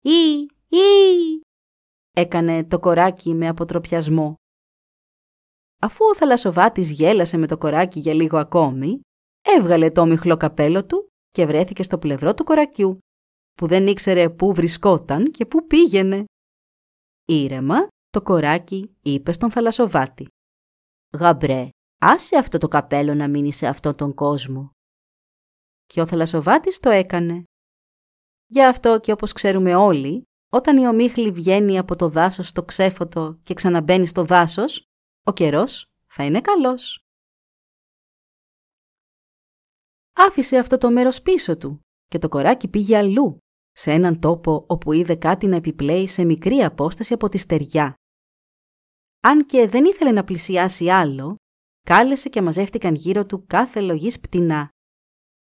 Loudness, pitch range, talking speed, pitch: -18 LUFS, 160-230 Hz, 130 wpm, 180 Hz